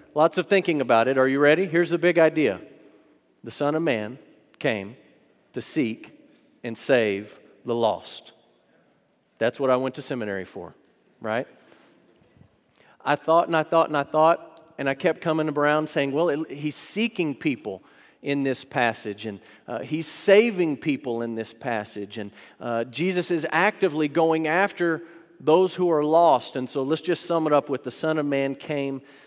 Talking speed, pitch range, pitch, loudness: 175 wpm, 130-165 Hz, 150 Hz, -24 LUFS